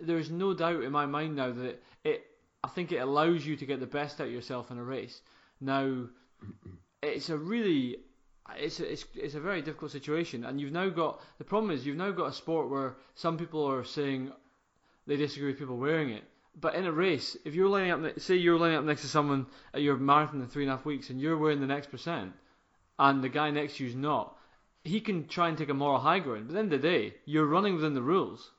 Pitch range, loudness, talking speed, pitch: 135-165 Hz, -31 LUFS, 245 wpm, 150 Hz